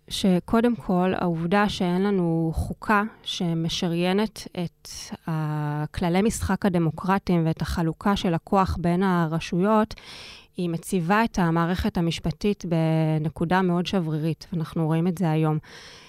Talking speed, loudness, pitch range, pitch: 110 wpm, -24 LUFS, 165-195 Hz, 175 Hz